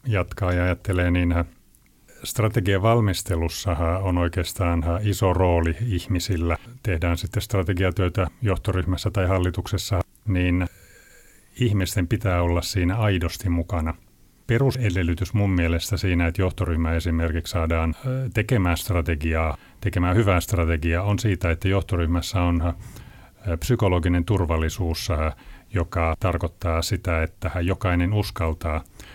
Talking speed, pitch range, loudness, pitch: 105 wpm, 85-100 Hz, -24 LUFS, 90 Hz